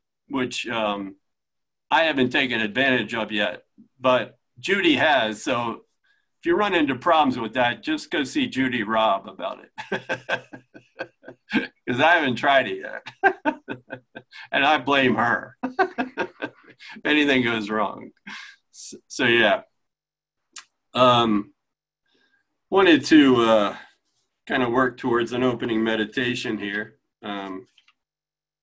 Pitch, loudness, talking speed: 130 Hz, -22 LUFS, 115 wpm